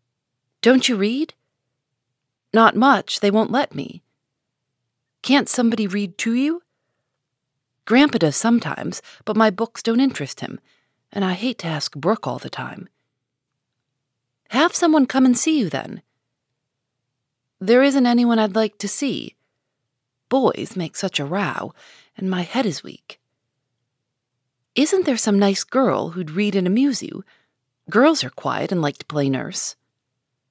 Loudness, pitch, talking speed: -19 LUFS, 190 Hz, 145 wpm